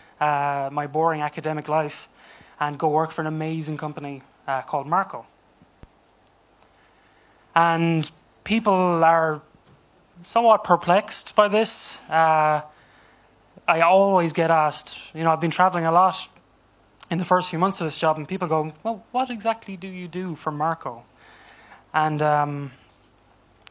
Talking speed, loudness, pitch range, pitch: 140 wpm, -22 LUFS, 150-180 Hz, 160 Hz